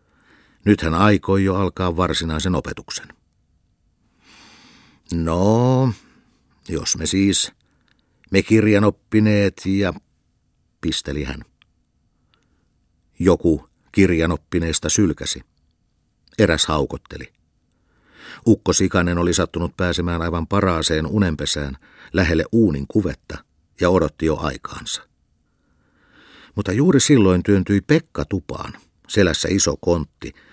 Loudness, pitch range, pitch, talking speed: -19 LUFS, 80-100 Hz, 90 Hz, 90 wpm